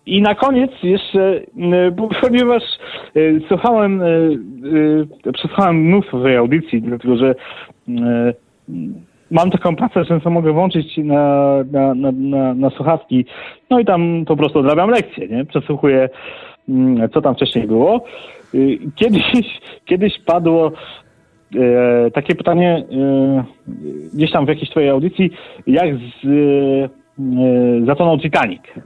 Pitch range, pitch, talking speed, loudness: 135-180 Hz, 155 Hz, 110 wpm, -15 LUFS